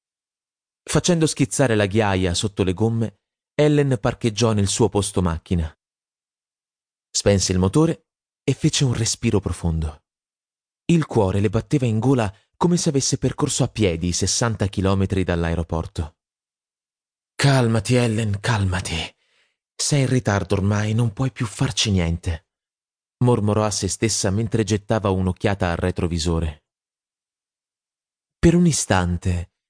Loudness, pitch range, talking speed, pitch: -21 LUFS, 95-125 Hz, 125 wpm, 105 Hz